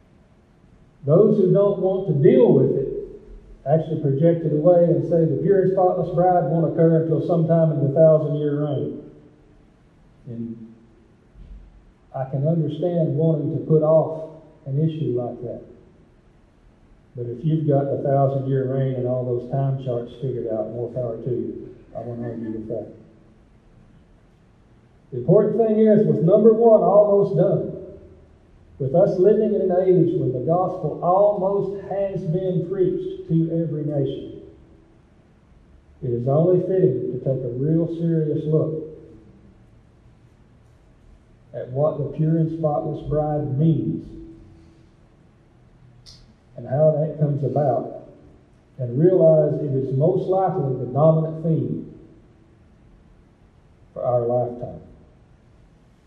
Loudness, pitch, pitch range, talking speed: -20 LUFS, 155 Hz, 125-175 Hz, 130 wpm